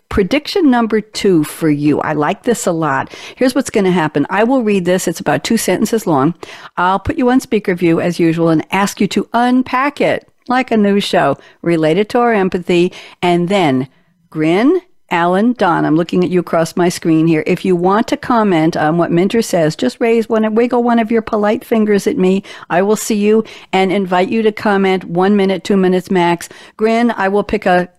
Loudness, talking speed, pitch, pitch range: -14 LUFS, 210 wpm, 195 Hz, 175-225 Hz